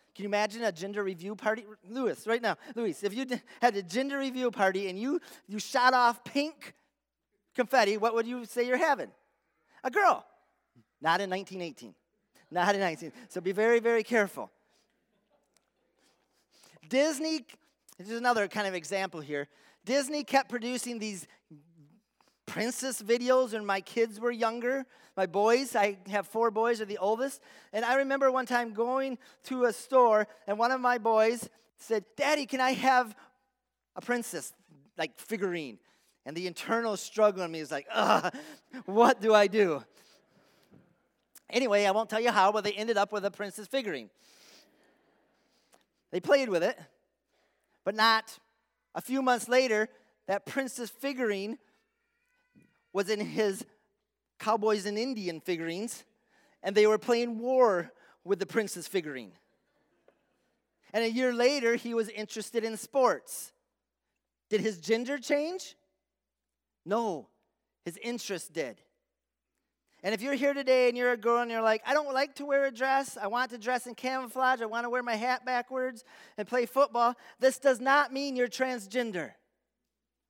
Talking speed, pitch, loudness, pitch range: 155 wpm, 230 Hz, -30 LUFS, 205-255 Hz